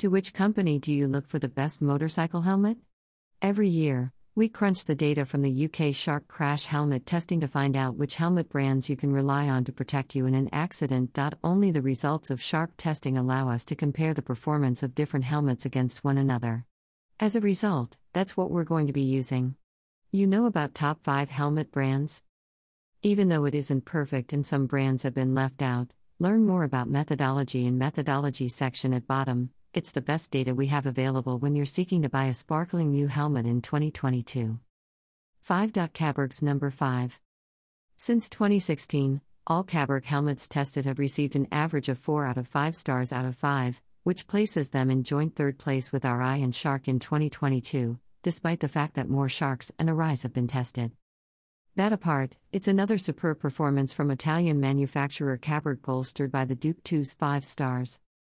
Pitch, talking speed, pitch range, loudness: 140 Hz, 185 wpm, 130-155 Hz, -28 LUFS